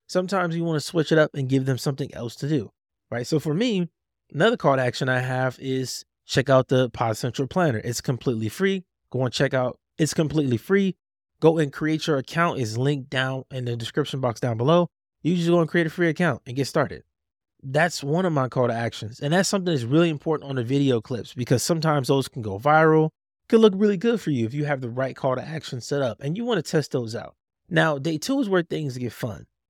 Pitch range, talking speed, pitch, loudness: 125-165 Hz, 245 wpm, 140 Hz, -24 LUFS